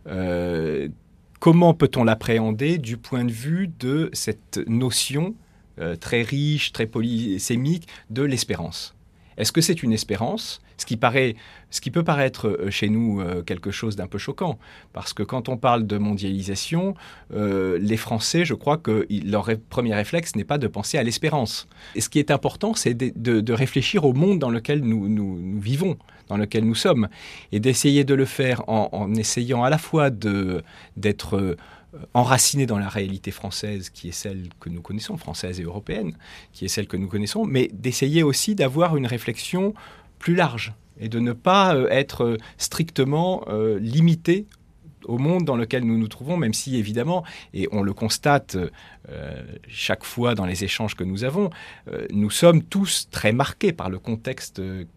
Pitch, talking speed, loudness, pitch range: 115 Hz, 180 wpm, -23 LUFS, 105-140 Hz